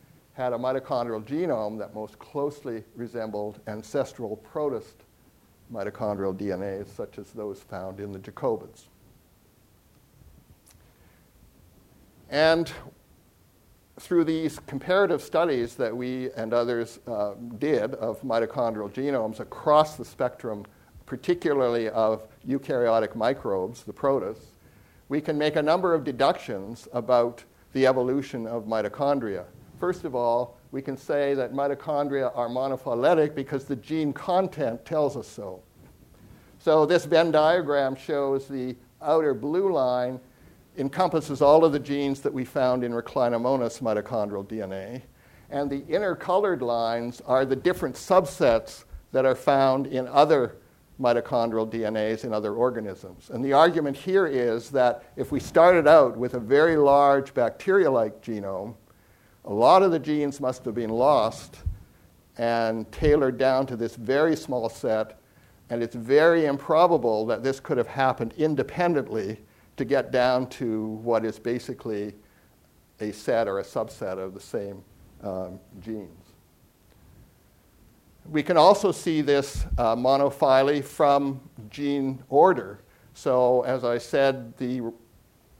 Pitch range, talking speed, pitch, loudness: 115-145 Hz, 130 wpm, 130 Hz, -25 LUFS